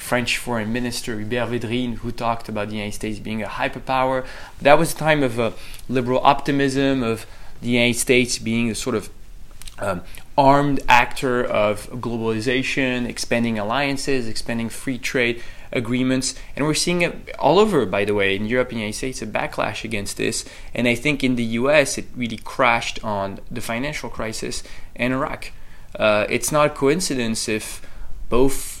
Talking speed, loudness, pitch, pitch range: 170 wpm, -21 LUFS, 120 Hz, 110-130 Hz